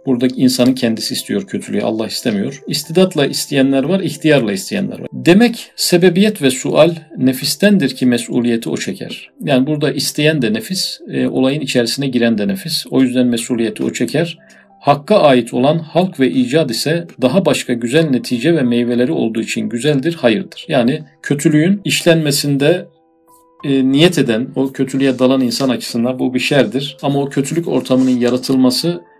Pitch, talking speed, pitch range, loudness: 135 Hz, 150 wpm, 125-165 Hz, -15 LUFS